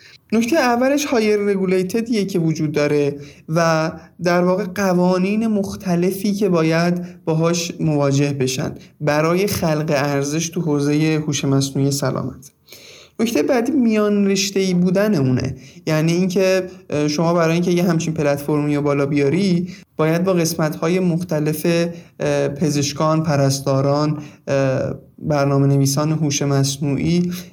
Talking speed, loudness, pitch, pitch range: 115 wpm, -18 LUFS, 160 Hz, 145-185 Hz